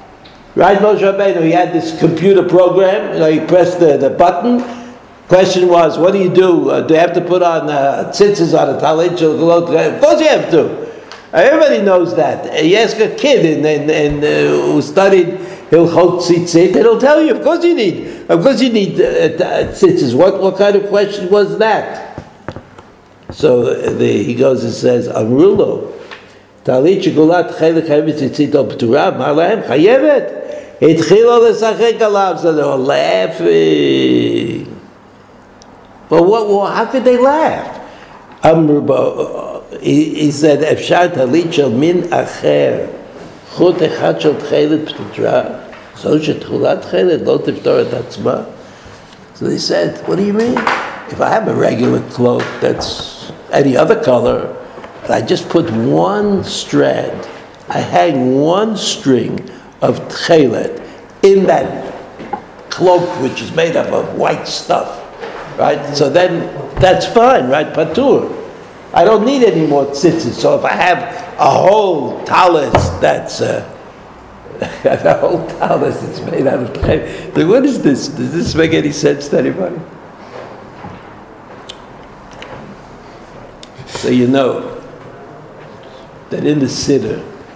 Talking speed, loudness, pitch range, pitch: 135 wpm, -12 LUFS, 160-245 Hz, 185 Hz